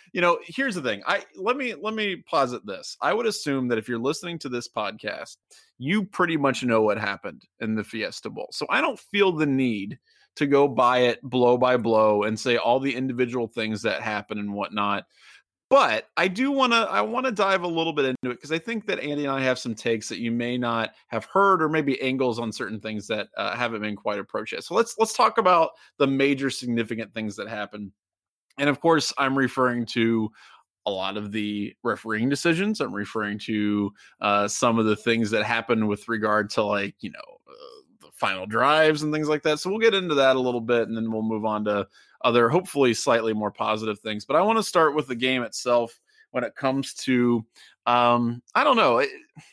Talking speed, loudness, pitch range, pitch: 220 wpm, -24 LUFS, 110-155 Hz, 125 Hz